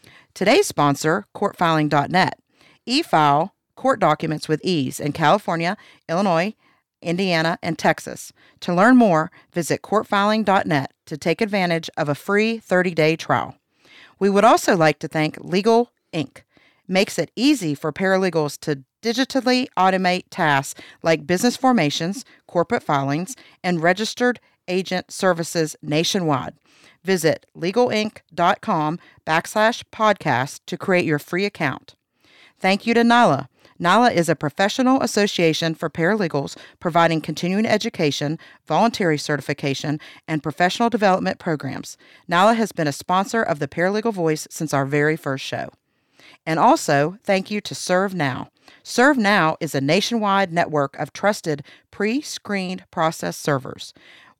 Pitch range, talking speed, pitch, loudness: 155-205 Hz, 120 wpm, 175 Hz, -20 LUFS